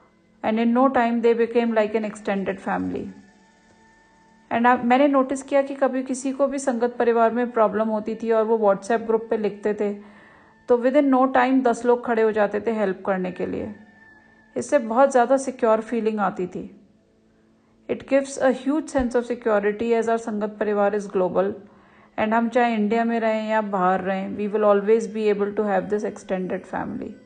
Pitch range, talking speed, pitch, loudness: 205-245 Hz, 185 wpm, 225 Hz, -22 LUFS